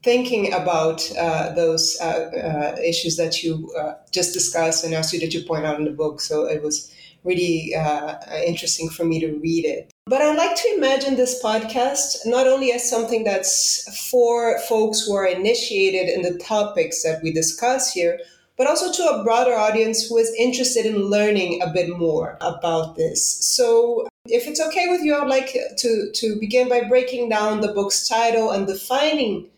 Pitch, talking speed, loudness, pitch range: 210 Hz, 185 wpm, -20 LUFS, 165-250 Hz